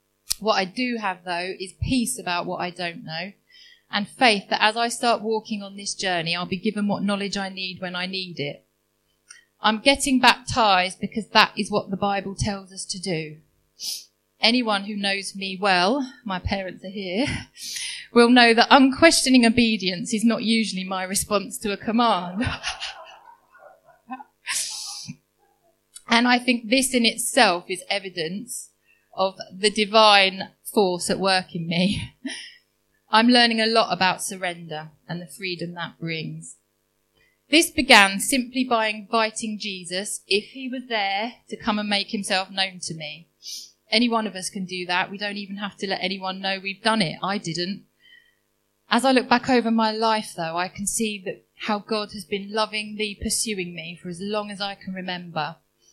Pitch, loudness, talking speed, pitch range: 205 Hz, -22 LUFS, 170 wpm, 185-230 Hz